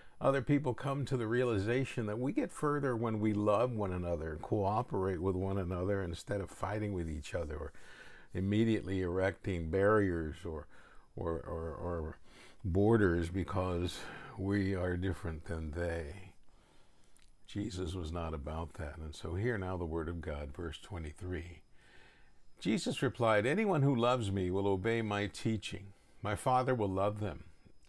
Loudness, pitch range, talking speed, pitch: -35 LUFS, 85-110 Hz, 150 wpm, 95 Hz